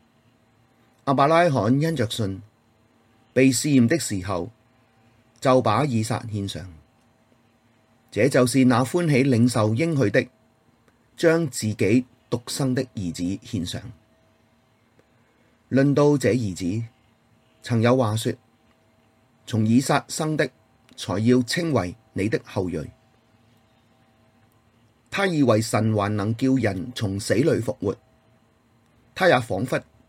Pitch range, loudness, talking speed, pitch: 110-130 Hz, -22 LUFS, 160 characters per minute, 115 Hz